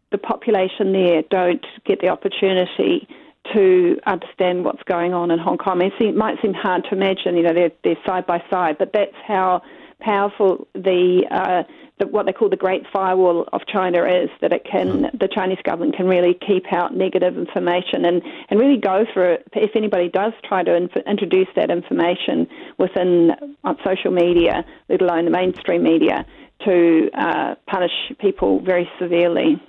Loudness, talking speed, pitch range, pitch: -19 LUFS, 175 wpm, 180-205 Hz, 185 Hz